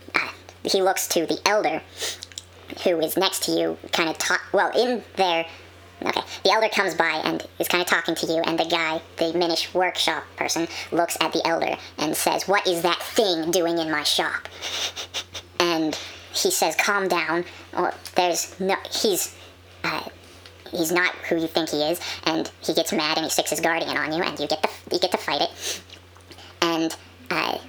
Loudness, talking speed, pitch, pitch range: -23 LUFS, 195 wpm, 165 Hz, 150-180 Hz